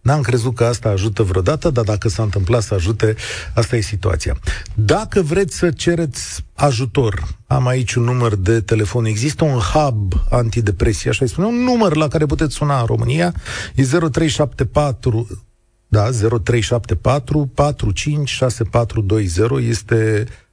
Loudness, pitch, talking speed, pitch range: -17 LUFS, 120 Hz, 135 wpm, 110-145 Hz